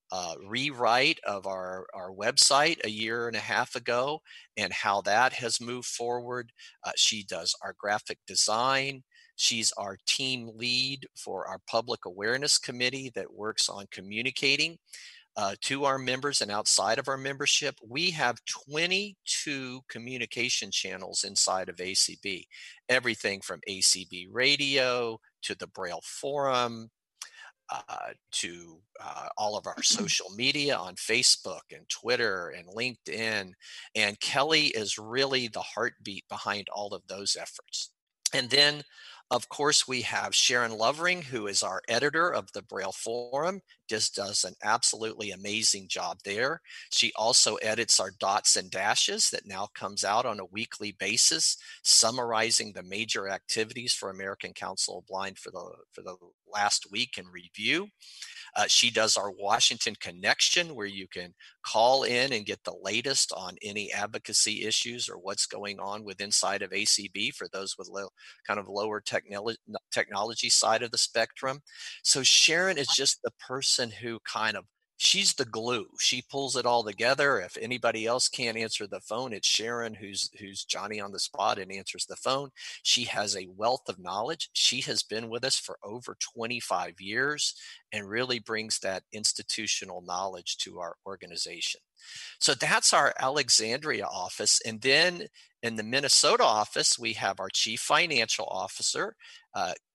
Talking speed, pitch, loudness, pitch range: 155 wpm, 120 Hz, -27 LUFS, 105-135 Hz